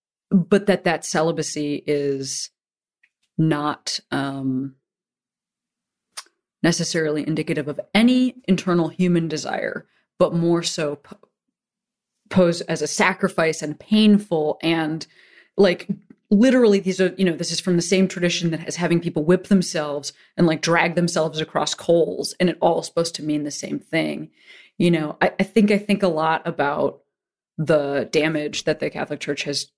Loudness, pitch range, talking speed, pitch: -21 LUFS, 155-190 Hz, 155 wpm, 170 Hz